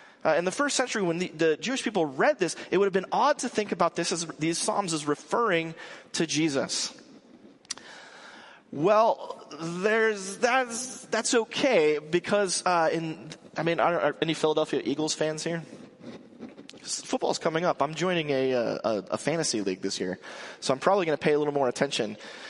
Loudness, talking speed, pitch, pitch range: -27 LUFS, 180 wpm, 170 Hz, 155-215 Hz